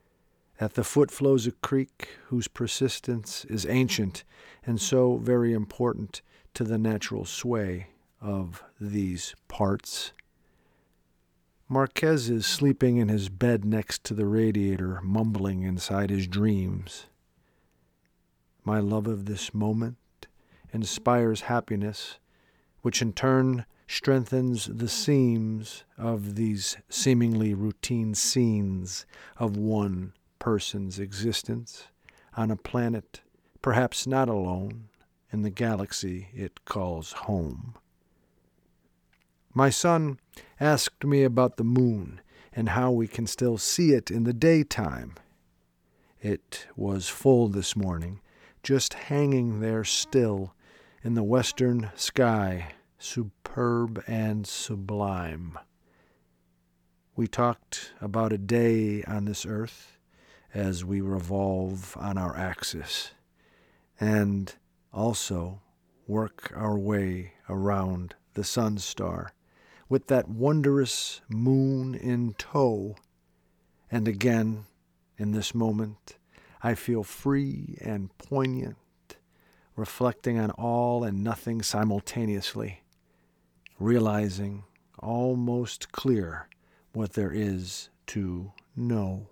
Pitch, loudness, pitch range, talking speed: 105 Hz, -28 LUFS, 95-120 Hz, 105 wpm